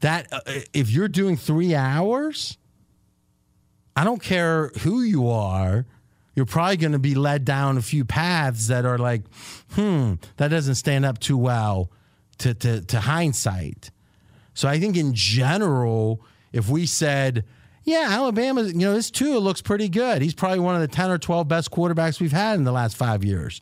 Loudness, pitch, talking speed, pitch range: -22 LUFS, 145 Hz, 185 wpm, 120-175 Hz